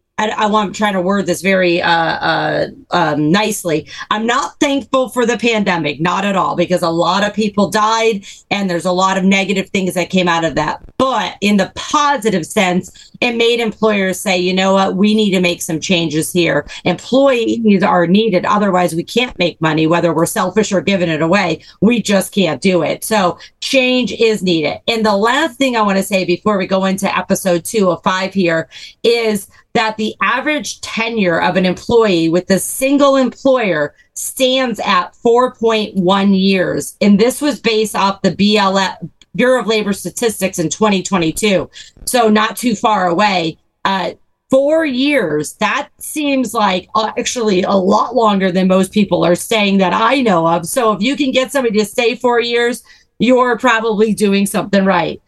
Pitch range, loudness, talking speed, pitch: 180-230 Hz, -14 LUFS, 180 wpm, 200 Hz